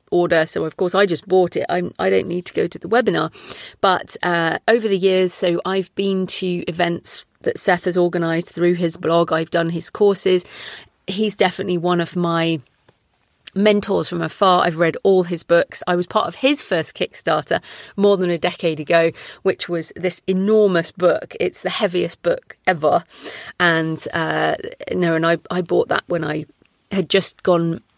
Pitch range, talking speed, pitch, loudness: 165-190 Hz, 185 wpm, 175 Hz, -19 LUFS